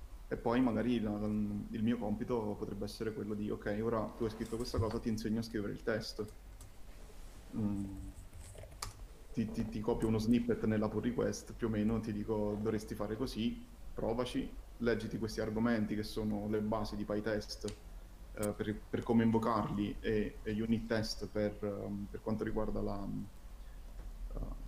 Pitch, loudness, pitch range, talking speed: 110 Hz, -37 LUFS, 105-110 Hz, 170 wpm